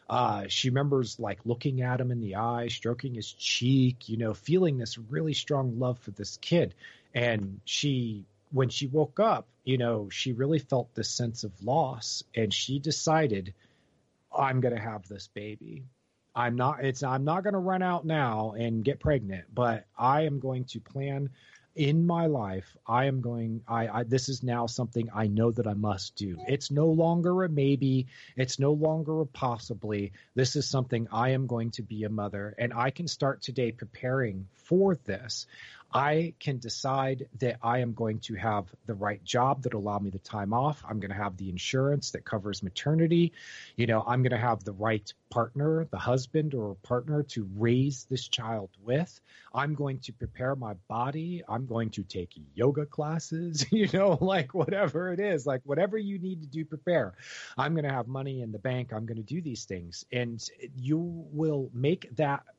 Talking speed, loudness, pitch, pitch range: 195 wpm, -30 LUFS, 125 Hz, 110-145 Hz